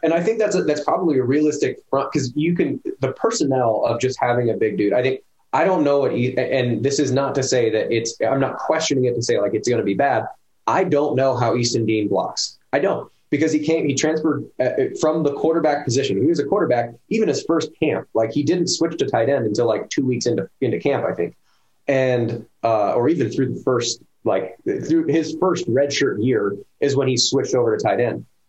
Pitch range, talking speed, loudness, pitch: 125-155 Hz, 235 wpm, -20 LUFS, 140 Hz